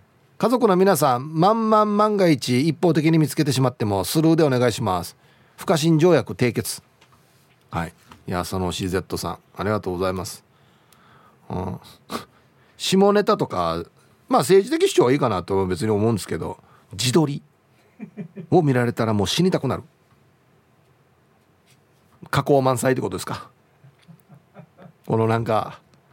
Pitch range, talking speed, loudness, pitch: 115-170 Hz, 280 characters per minute, -21 LUFS, 135 Hz